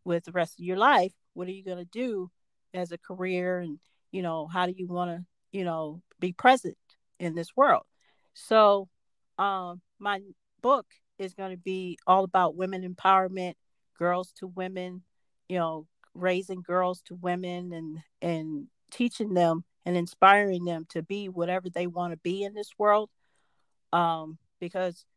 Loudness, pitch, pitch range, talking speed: -28 LUFS, 180 Hz, 175-190 Hz, 165 wpm